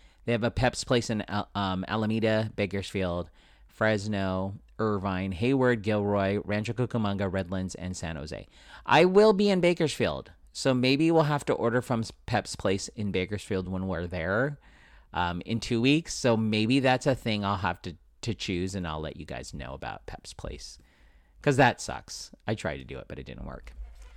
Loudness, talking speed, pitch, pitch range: -28 LUFS, 180 wpm, 100 Hz, 85-115 Hz